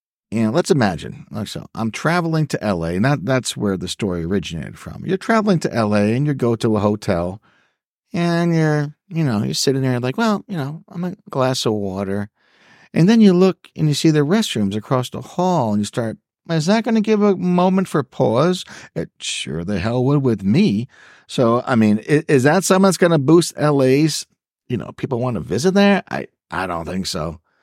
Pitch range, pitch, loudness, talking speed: 110-180 Hz, 145 Hz, -18 LUFS, 215 wpm